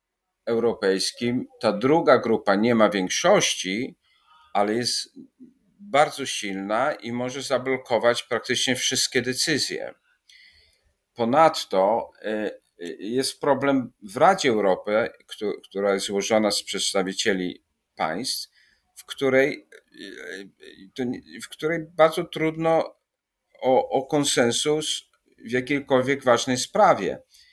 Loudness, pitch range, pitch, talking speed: -23 LUFS, 115-155 Hz, 130 Hz, 90 wpm